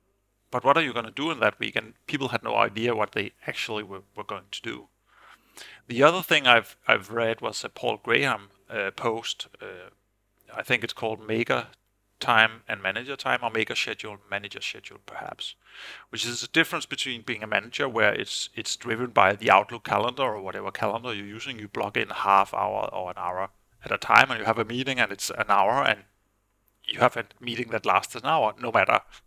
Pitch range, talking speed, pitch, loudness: 105-120 Hz, 210 wpm, 115 Hz, -25 LUFS